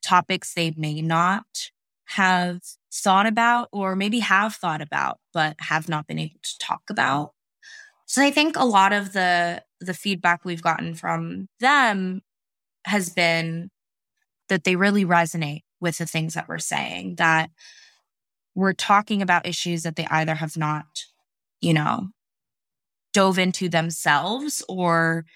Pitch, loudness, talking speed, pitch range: 175 Hz, -22 LUFS, 145 wpm, 160-200 Hz